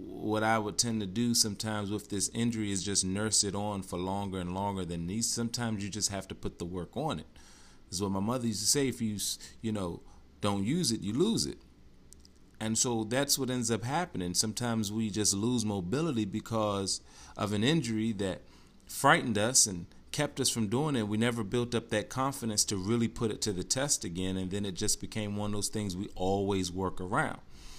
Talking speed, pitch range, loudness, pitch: 215 wpm, 95-115 Hz, -31 LUFS, 105 Hz